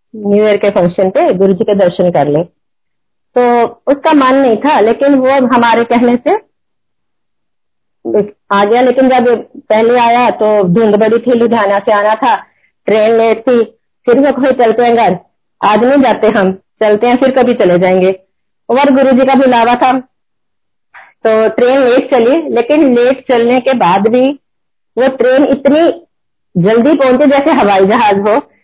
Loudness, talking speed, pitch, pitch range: -9 LUFS, 165 wpm, 235 Hz, 210-260 Hz